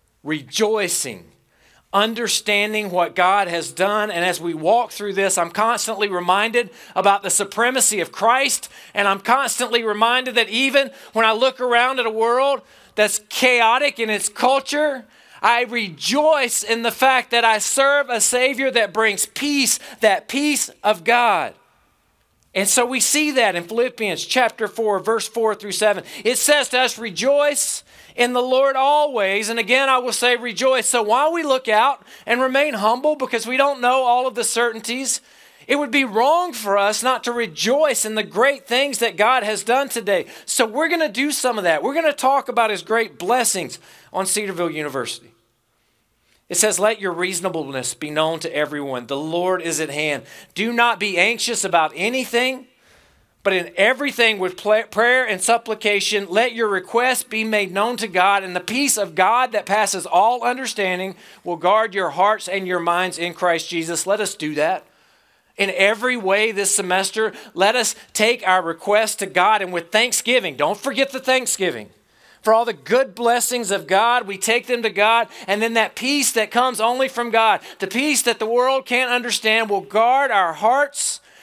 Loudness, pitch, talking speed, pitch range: -18 LUFS, 225 Hz, 180 wpm, 195-250 Hz